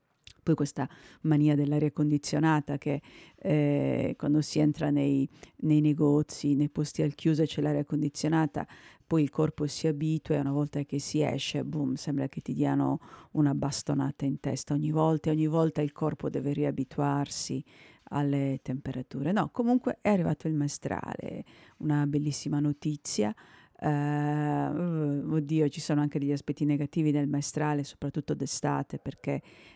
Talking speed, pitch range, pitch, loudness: 145 wpm, 145-155 Hz, 145 Hz, -29 LUFS